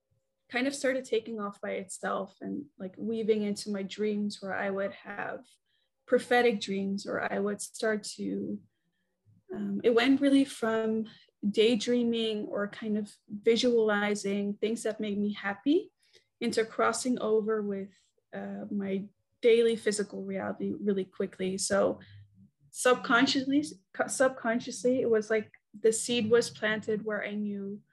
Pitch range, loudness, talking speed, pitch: 200-235 Hz, -30 LUFS, 135 wpm, 215 Hz